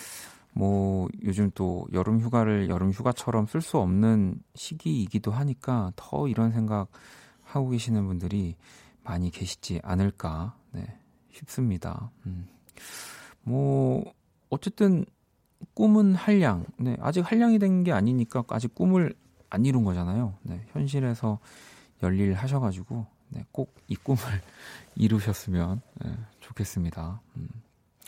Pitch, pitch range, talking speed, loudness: 110 Hz, 95-130 Hz, 245 characters per minute, -27 LUFS